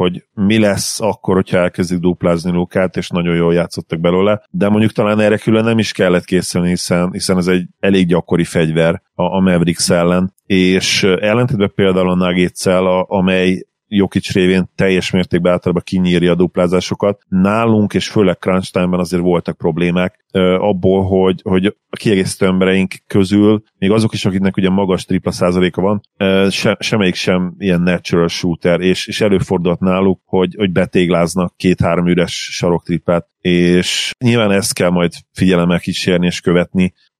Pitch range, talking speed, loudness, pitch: 90-95 Hz, 150 wpm, -14 LUFS, 95 Hz